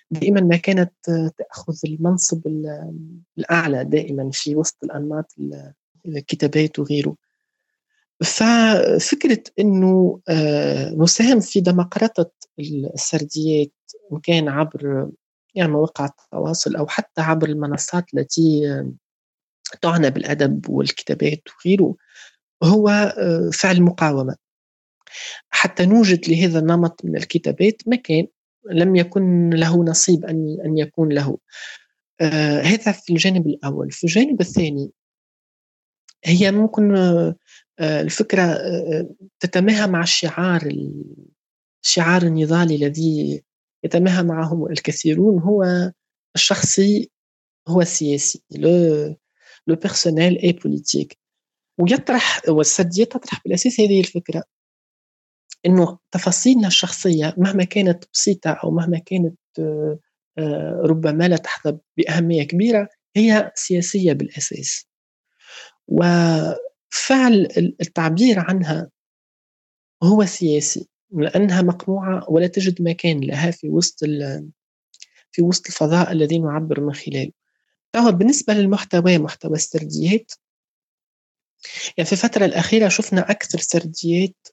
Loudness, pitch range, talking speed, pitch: -18 LUFS, 155-190 Hz, 95 wpm, 170 Hz